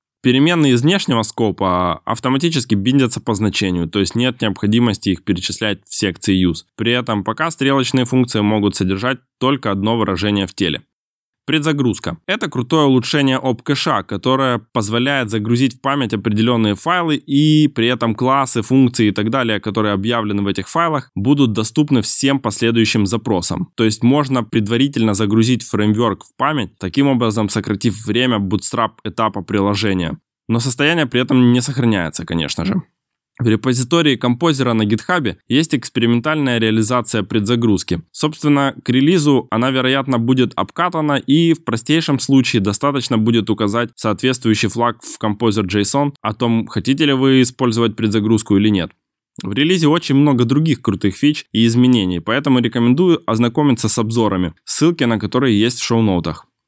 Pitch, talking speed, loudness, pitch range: 120 Hz, 150 wpm, -16 LUFS, 105-135 Hz